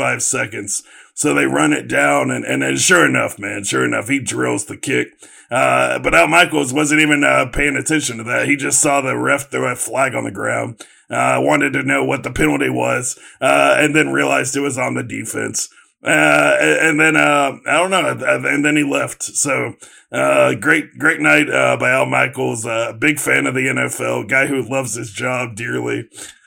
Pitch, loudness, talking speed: 130 Hz, -15 LUFS, 210 wpm